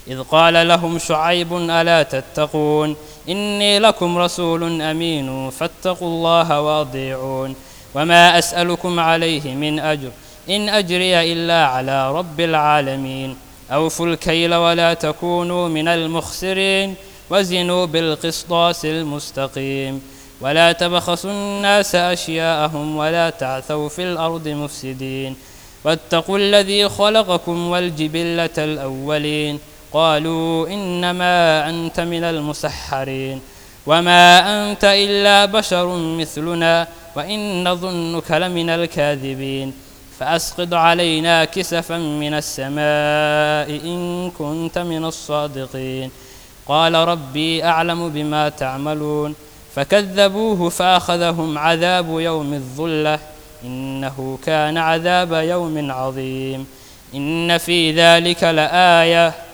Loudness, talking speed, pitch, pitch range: -17 LUFS, 90 wpm, 165 Hz, 150-175 Hz